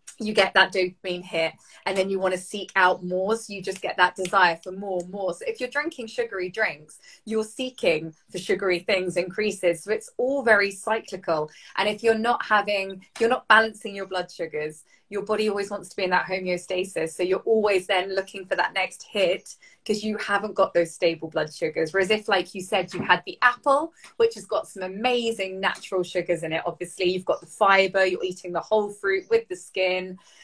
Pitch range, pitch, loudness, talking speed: 180-215 Hz, 195 Hz, -24 LUFS, 215 wpm